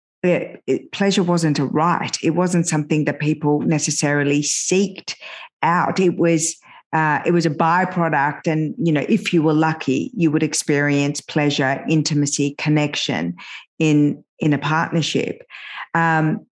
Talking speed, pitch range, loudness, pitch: 140 wpm, 145-170 Hz, -19 LUFS, 155 Hz